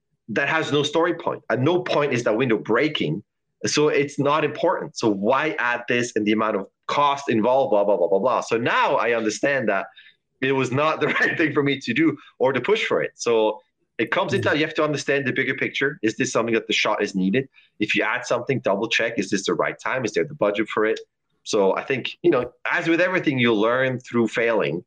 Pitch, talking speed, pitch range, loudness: 140 Hz, 240 wpm, 120-165 Hz, -22 LUFS